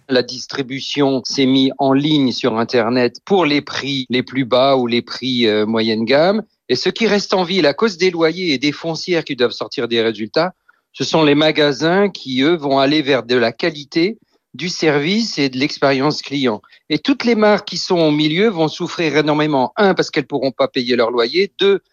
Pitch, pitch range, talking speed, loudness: 145 Hz, 130-175 Hz, 210 wpm, -16 LUFS